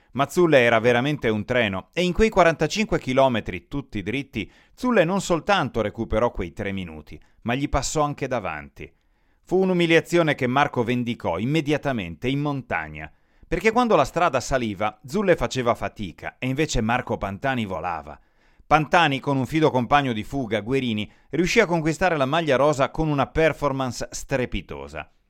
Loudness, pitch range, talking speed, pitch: -23 LUFS, 105-155 Hz, 150 wpm, 130 Hz